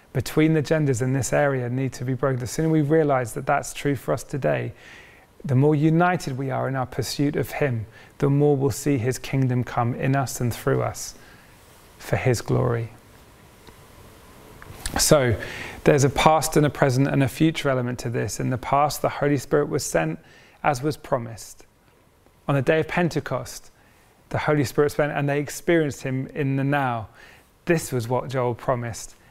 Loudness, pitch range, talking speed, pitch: -23 LUFS, 125-150 Hz, 185 wpm, 135 Hz